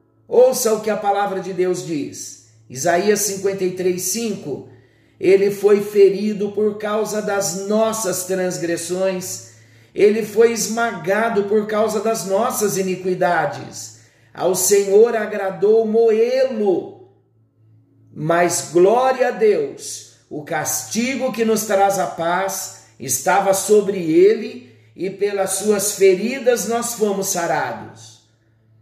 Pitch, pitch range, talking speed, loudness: 200 Hz, 180-220 Hz, 110 wpm, -18 LUFS